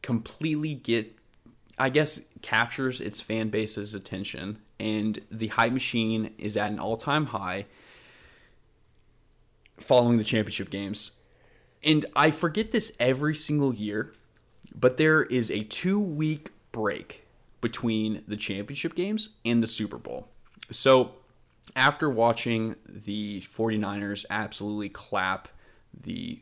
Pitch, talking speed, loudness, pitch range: 115 Hz, 115 wpm, -27 LUFS, 105-145 Hz